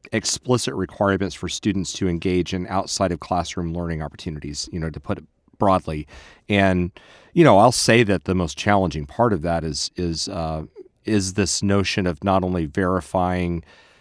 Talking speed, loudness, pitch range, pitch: 170 wpm, -21 LUFS, 85-100 Hz, 90 Hz